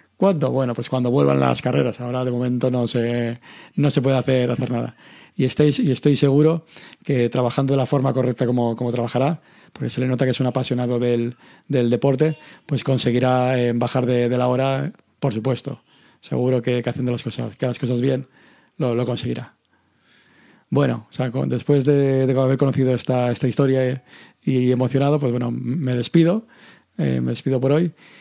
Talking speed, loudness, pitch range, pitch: 190 wpm, -21 LUFS, 120-140 Hz, 130 Hz